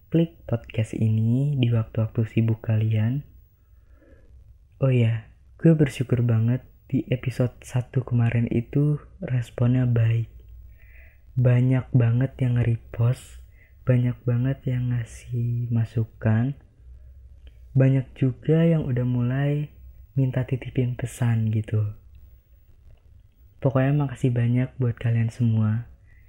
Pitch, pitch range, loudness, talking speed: 120 Hz, 110-130 Hz, -24 LUFS, 100 wpm